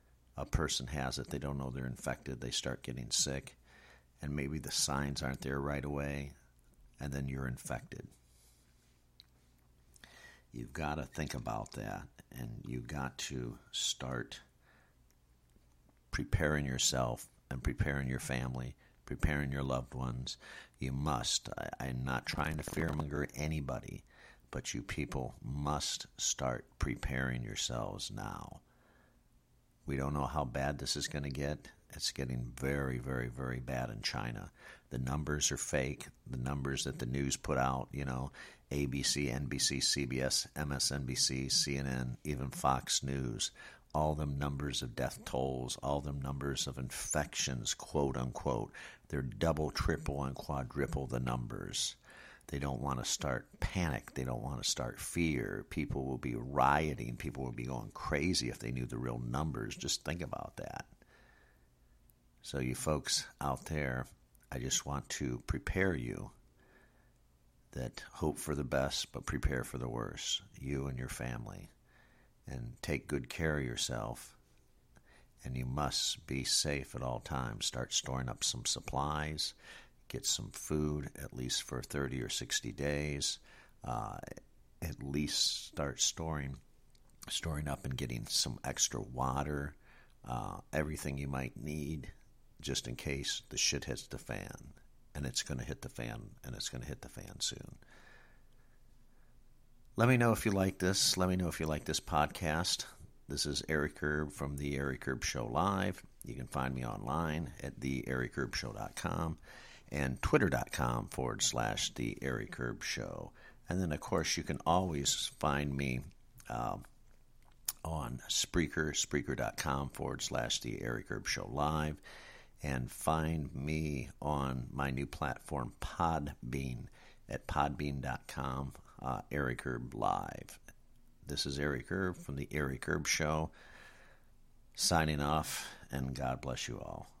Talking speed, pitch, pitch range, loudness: 145 wpm, 70 Hz, 65-75 Hz, -37 LUFS